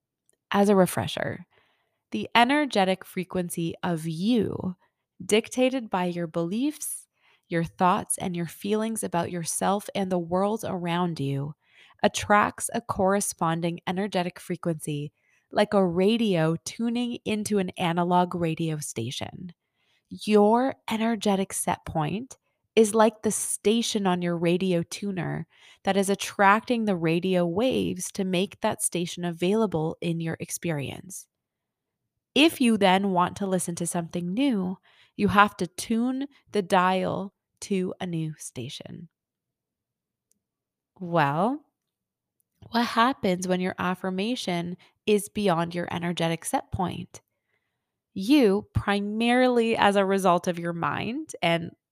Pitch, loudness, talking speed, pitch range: 185 Hz, -26 LUFS, 120 wpm, 175-215 Hz